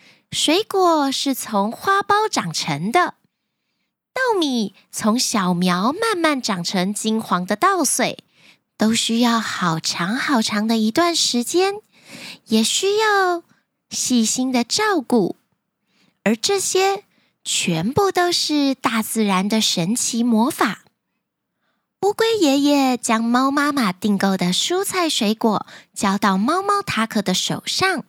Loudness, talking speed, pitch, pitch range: -19 LUFS, 175 characters per minute, 240 Hz, 215-355 Hz